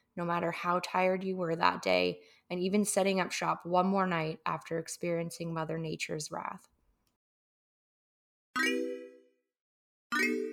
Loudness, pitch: -32 LUFS, 165 Hz